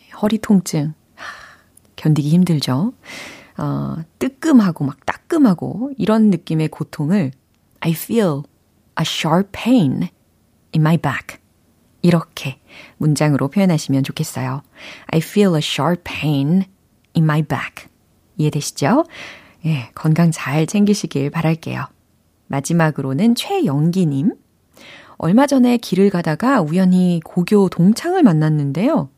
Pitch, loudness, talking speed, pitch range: 160 Hz, -17 LUFS, 290 characters per minute, 145-200 Hz